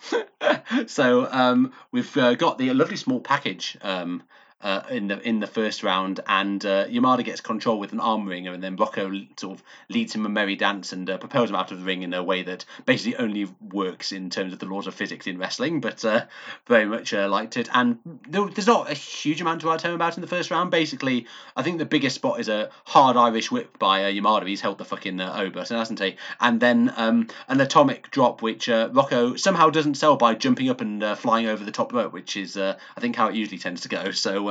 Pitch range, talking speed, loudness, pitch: 100-160 Hz, 240 wpm, -23 LUFS, 120 Hz